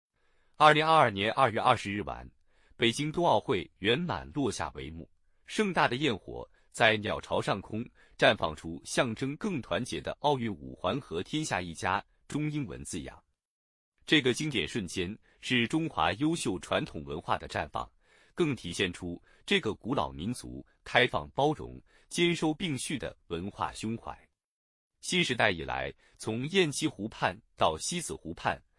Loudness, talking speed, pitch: -30 LUFS, 230 characters per minute, 115 Hz